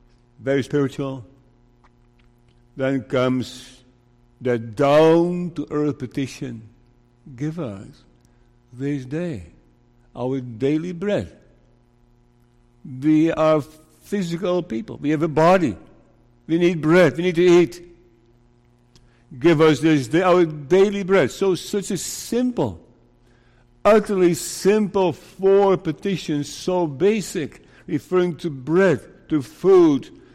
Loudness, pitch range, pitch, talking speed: -20 LUFS, 120-175 Hz, 145 Hz, 105 wpm